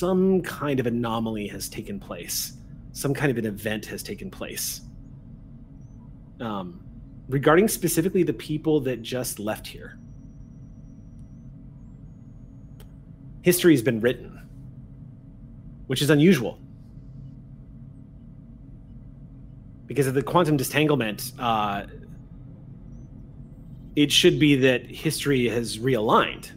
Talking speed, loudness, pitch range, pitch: 100 wpm, -24 LUFS, 125-140 Hz, 130 Hz